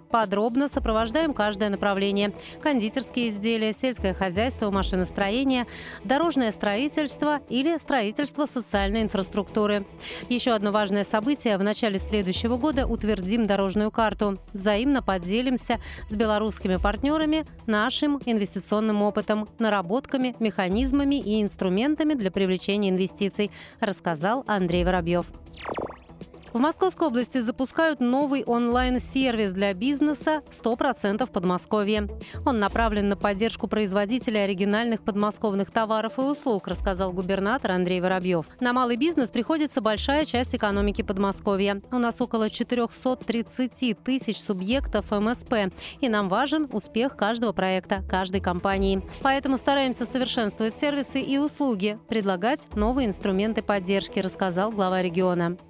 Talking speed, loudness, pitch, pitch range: 110 wpm, -25 LUFS, 220 Hz, 200-255 Hz